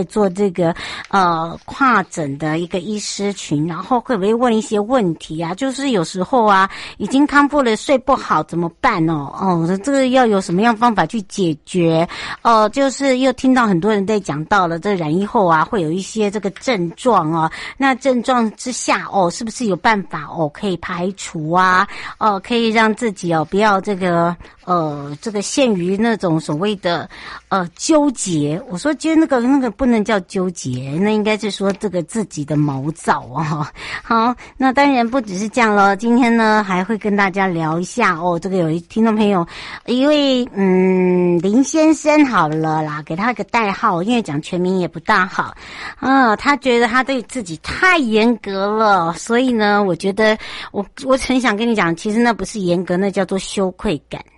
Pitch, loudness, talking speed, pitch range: 205 Hz, -17 LUFS, 270 characters per minute, 175-235 Hz